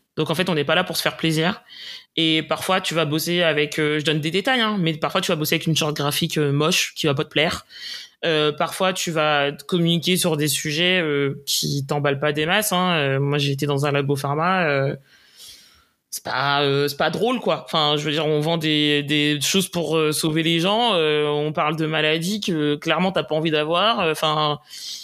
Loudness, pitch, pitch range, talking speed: -20 LUFS, 155 Hz, 150-170 Hz, 230 wpm